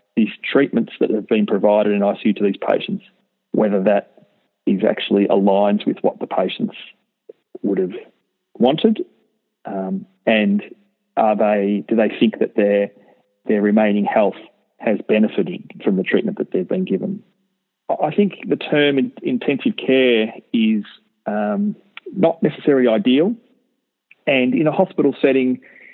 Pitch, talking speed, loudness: 130 Hz, 140 wpm, -18 LUFS